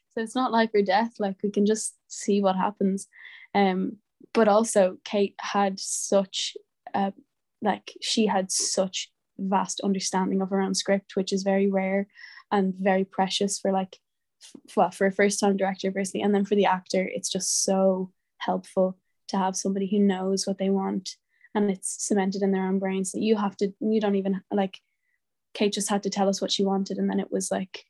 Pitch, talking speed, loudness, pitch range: 195 Hz, 200 wpm, -26 LUFS, 190-205 Hz